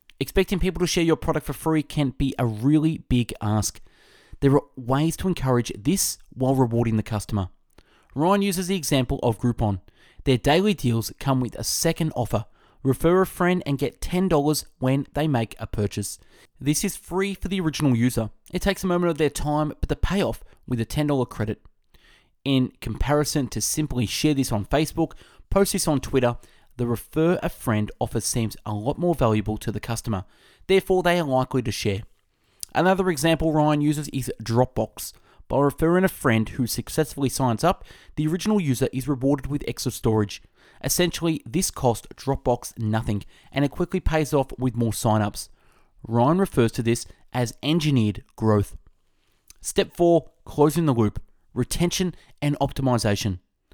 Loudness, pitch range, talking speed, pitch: -24 LUFS, 115-160 Hz, 170 wpm, 135 Hz